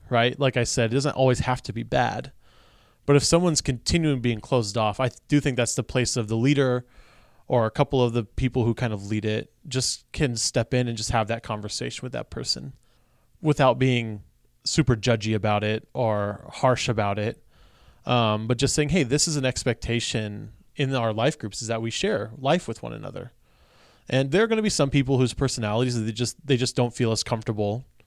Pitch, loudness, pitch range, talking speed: 120 Hz, -24 LUFS, 110-135 Hz, 210 wpm